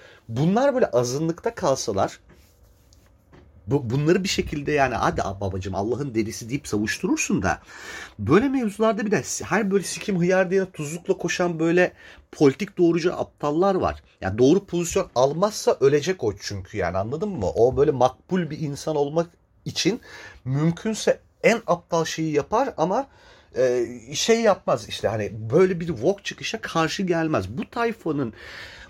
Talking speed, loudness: 145 wpm, -23 LUFS